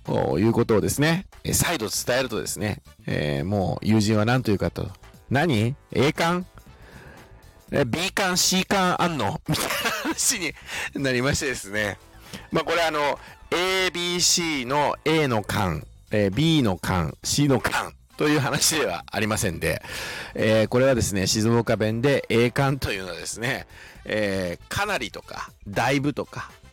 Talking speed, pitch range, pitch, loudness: 270 characters per minute, 105-150 Hz, 120 Hz, -23 LUFS